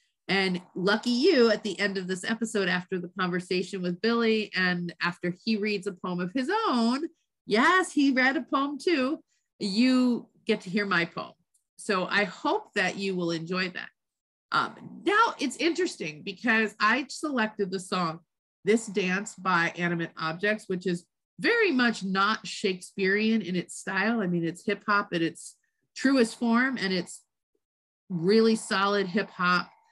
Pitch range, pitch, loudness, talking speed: 185-235 Hz, 205 Hz, -27 LUFS, 160 wpm